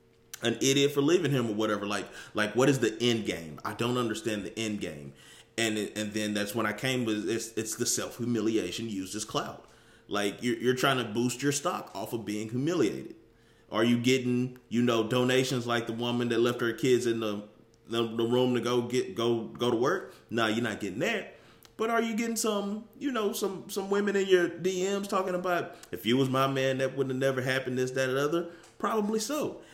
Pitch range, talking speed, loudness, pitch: 110-140 Hz, 220 wpm, -29 LUFS, 120 Hz